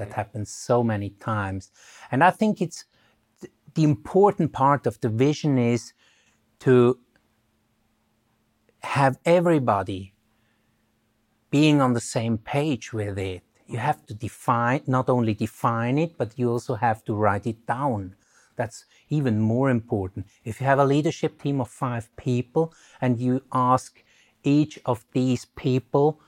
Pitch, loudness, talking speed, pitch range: 125 Hz, -24 LUFS, 145 wpm, 110-140 Hz